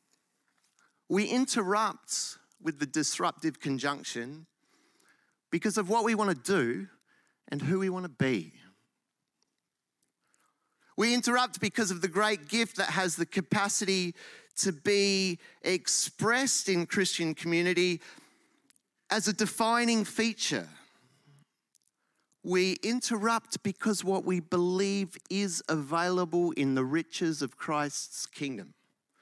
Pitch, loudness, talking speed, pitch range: 190 Hz, -30 LUFS, 110 wpm, 165-215 Hz